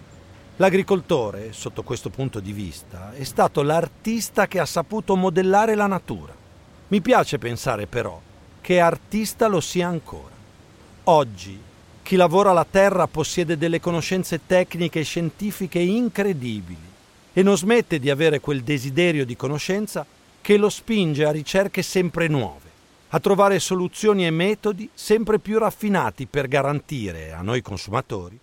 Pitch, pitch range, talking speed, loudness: 165 Hz, 125-195 Hz, 135 wpm, -21 LUFS